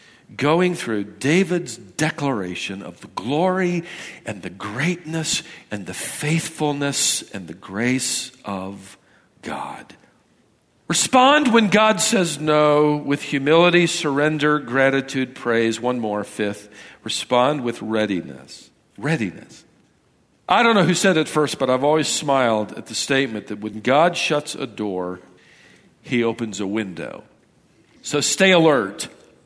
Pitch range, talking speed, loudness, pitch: 110-160 Hz, 125 wpm, -20 LUFS, 140 Hz